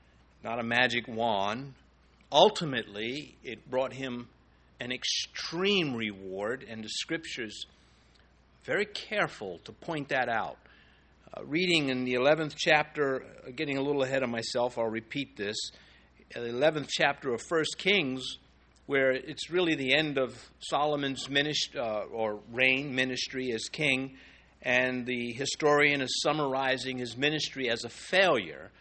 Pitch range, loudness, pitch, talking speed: 115-145 Hz, -29 LUFS, 130 Hz, 135 wpm